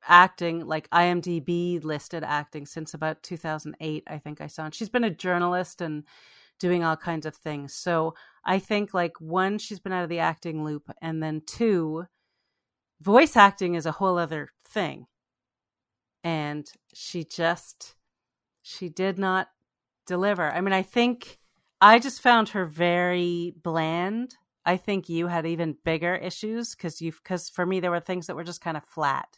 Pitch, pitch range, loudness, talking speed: 175 Hz, 160-185 Hz, -26 LUFS, 170 wpm